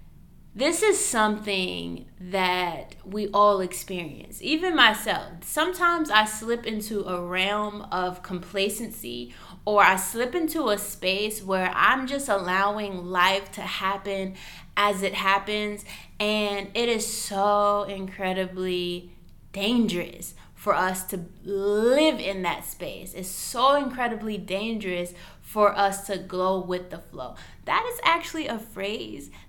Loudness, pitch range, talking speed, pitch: -25 LUFS, 185-220 Hz, 125 wpm, 200 Hz